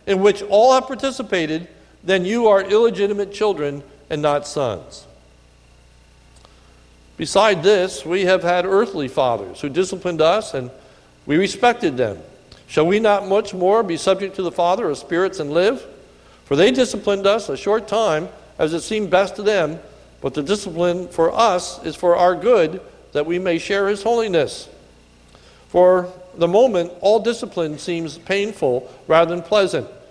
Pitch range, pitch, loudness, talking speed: 155-205 Hz, 180 Hz, -19 LUFS, 155 wpm